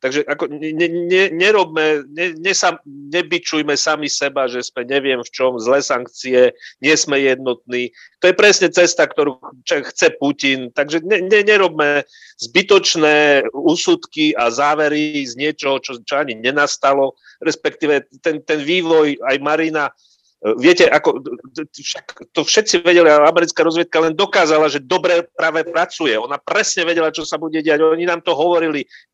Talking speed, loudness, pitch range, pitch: 145 wpm, -15 LUFS, 140-175 Hz, 155 Hz